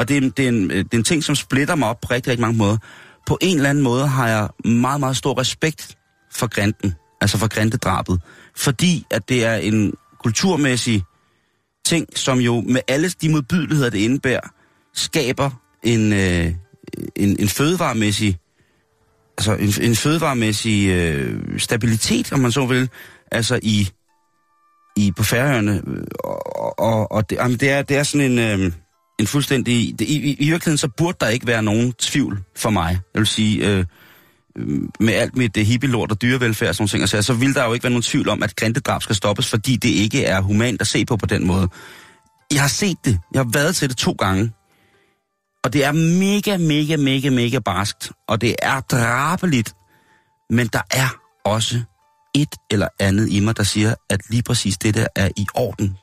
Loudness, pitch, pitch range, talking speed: -19 LUFS, 120 Hz, 105-140 Hz, 185 wpm